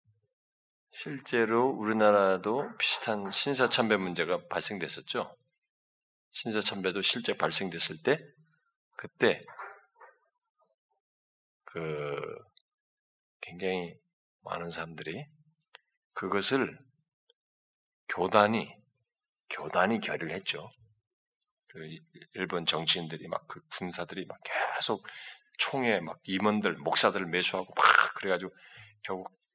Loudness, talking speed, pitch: -30 LUFS, 200 characters per minute, 135 Hz